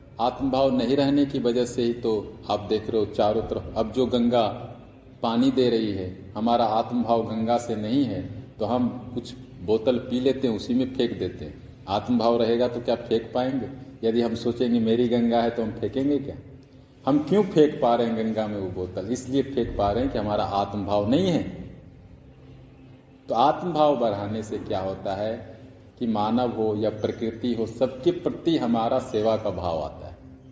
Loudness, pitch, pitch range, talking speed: -25 LUFS, 120 Hz, 110-130 Hz, 190 wpm